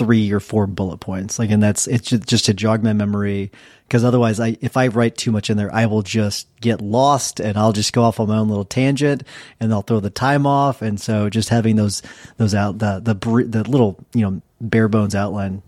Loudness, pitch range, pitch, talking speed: -18 LUFS, 105-120 Hz, 110 Hz, 235 wpm